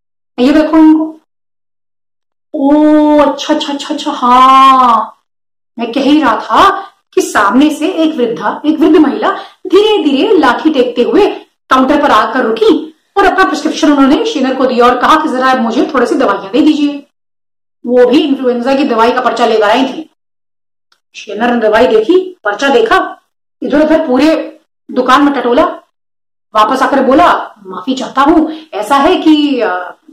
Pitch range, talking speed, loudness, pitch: 250-320 Hz, 155 wpm, -9 LUFS, 285 Hz